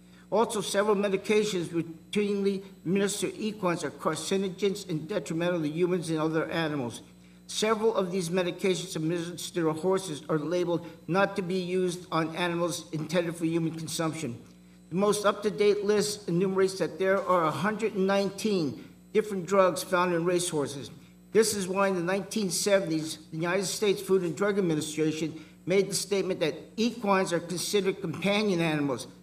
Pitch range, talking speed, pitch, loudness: 165-195 Hz, 150 wpm, 180 Hz, -28 LUFS